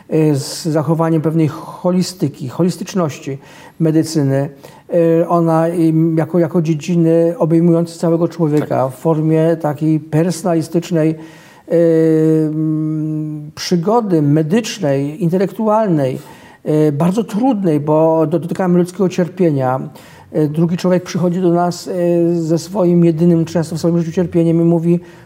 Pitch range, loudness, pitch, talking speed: 155-175 Hz, -15 LUFS, 165 Hz, 95 wpm